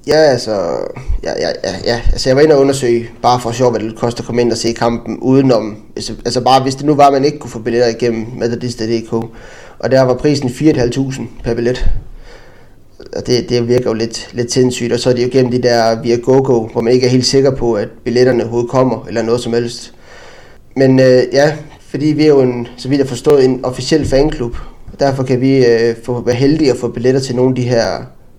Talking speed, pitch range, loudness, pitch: 230 wpm, 115-130 Hz, -13 LUFS, 125 Hz